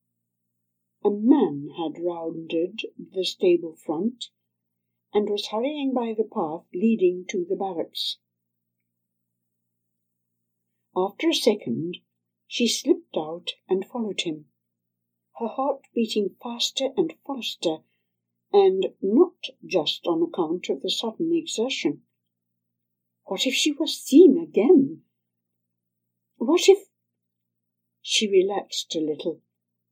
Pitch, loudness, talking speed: 170 Hz, -24 LUFS, 105 wpm